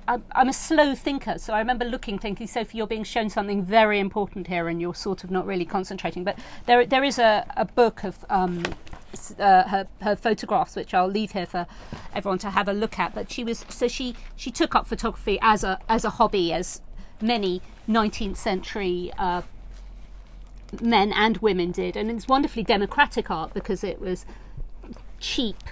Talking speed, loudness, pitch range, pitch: 185 wpm, -24 LUFS, 190-230 Hz, 210 Hz